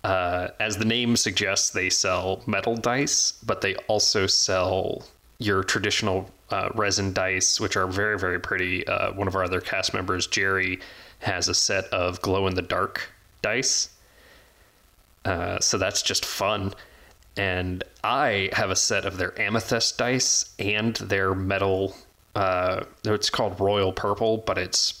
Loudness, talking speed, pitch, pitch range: -24 LUFS, 155 wpm, 100 Hz, 95-110 Hz